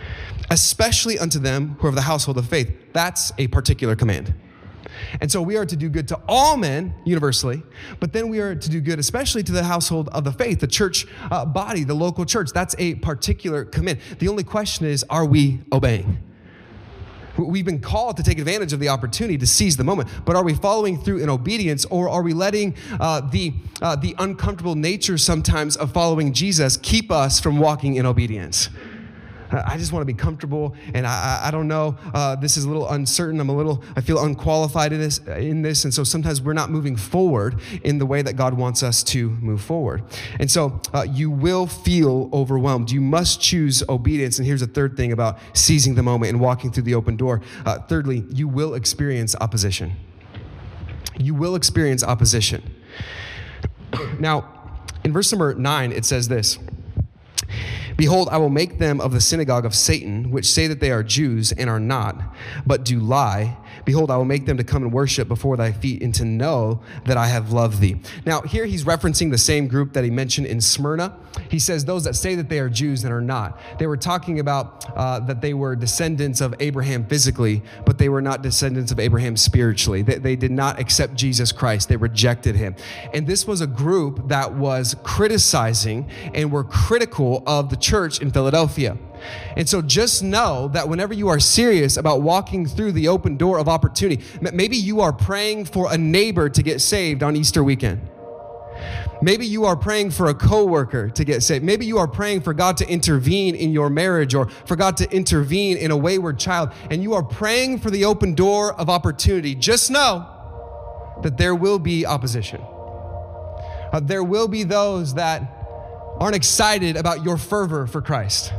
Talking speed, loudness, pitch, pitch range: 195 wpm, -20 LUFS, 140 Hz, 115-165 Hz